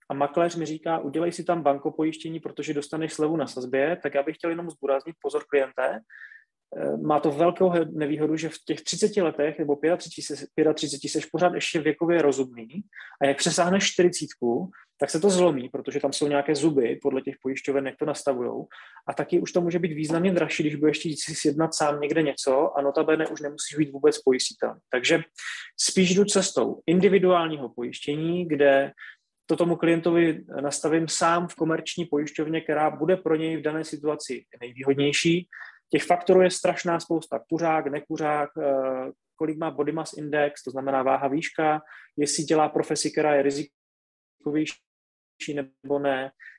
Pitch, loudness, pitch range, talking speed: 155 Hz, -25 LUFS, 140-165 Hz, 165 wpm